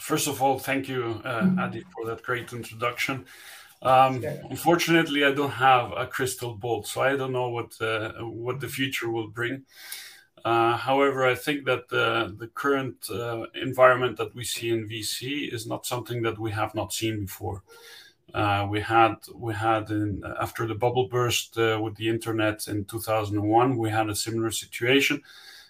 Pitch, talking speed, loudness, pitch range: 115 Hz, 180 wpm, -26 LUFS, 110-130 Hz